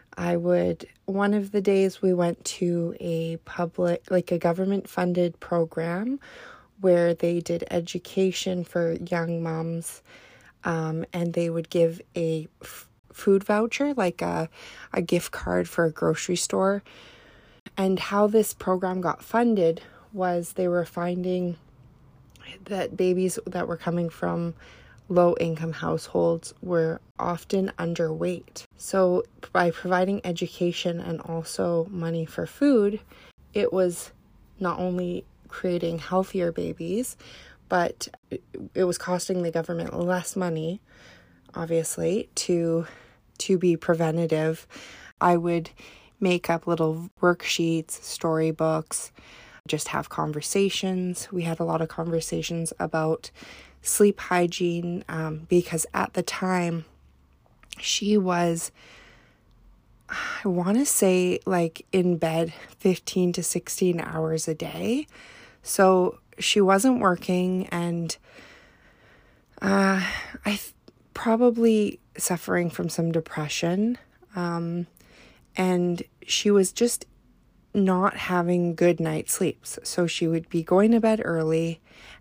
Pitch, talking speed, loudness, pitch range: 175 Hz, 115 wpm, -25 LUFS, 165-185 Hz